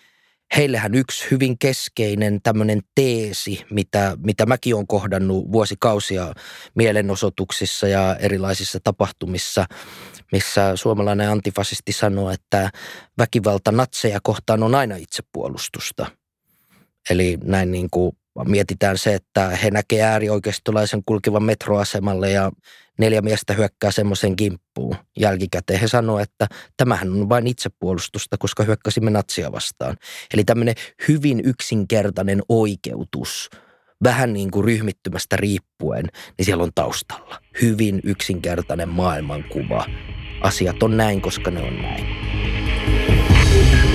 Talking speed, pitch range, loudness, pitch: 110 wpm, 95-110 Hz, -20 LUFS, 105 Hz